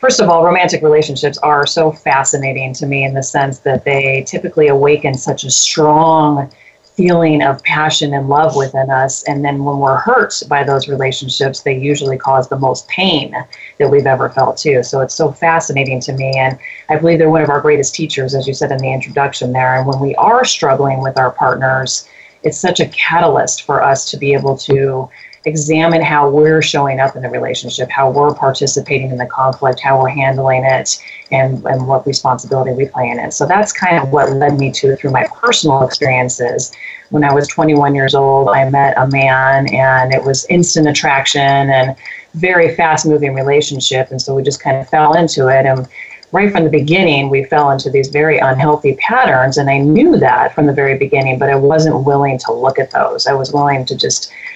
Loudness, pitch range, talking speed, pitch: -12 LUFS, 135-150 Hz, 205 wpm, 140 Hz